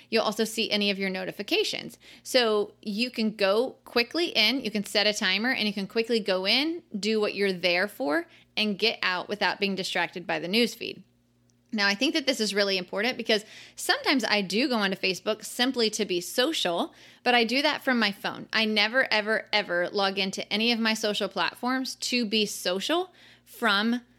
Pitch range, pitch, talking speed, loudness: 195-245 Hz, 215 Hz, 195 wpm, -26 LUFS